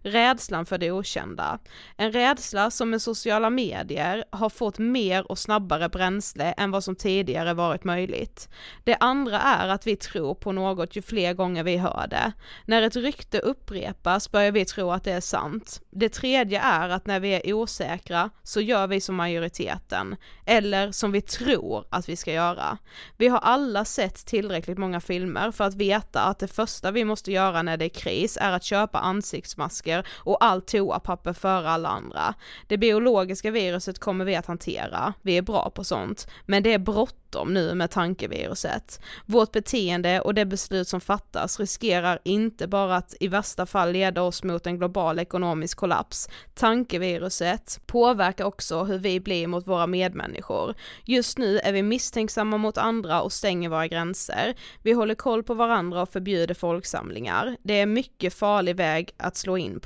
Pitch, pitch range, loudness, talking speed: 195 Hz, 180-220 Hz, -25 LUFS, 175 wpm